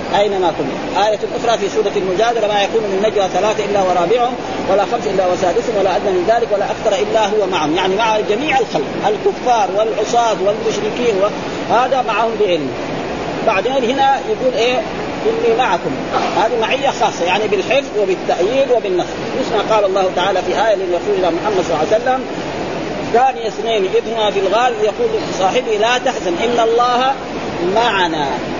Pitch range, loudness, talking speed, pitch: 200-245 Hz, -16 LUFS, 155 wpm, 220 Hz